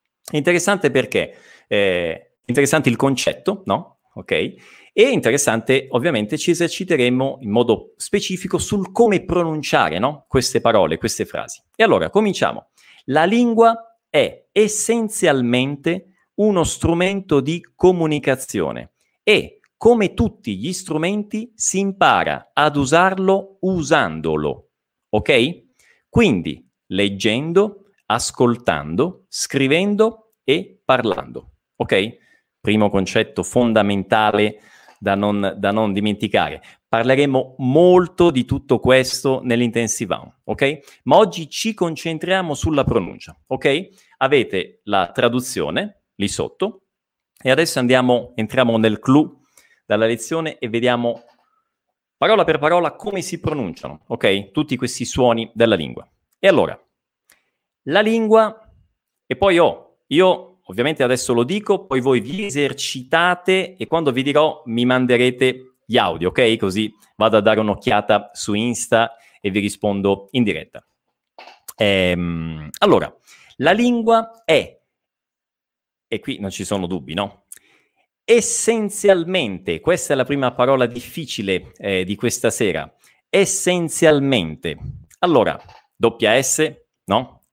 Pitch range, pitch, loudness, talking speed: 115-185 Hz, 135 Hz, -18 LUFS, 115 wpm